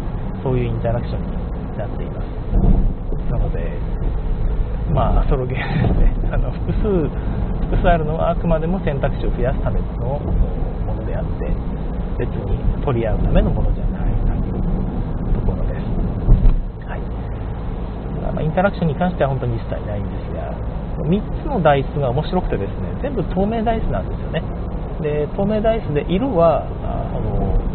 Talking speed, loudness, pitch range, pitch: 335 characters per minute, -21 LUFS, 120-170 Hz, 150 Hz